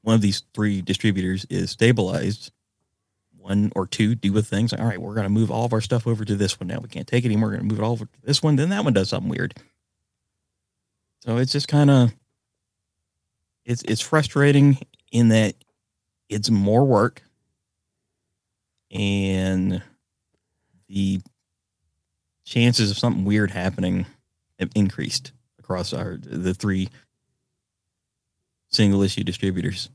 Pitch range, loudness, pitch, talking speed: 95-120 Hz, -22 LUFS, 105 Hz, 155 wpm